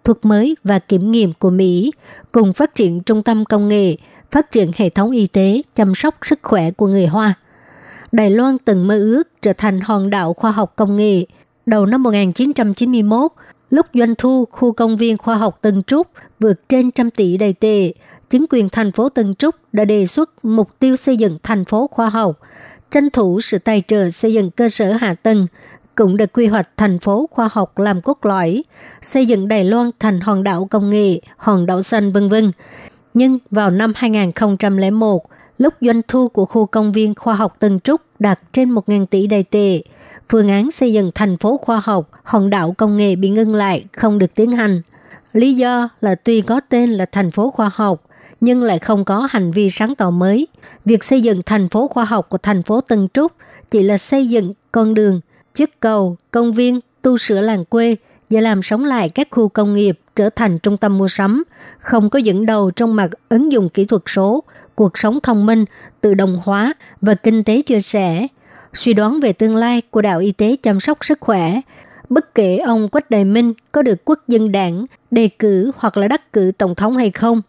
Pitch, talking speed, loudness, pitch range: 215 Hz, 210 wpm, -15 LUFS, 200-235 Hz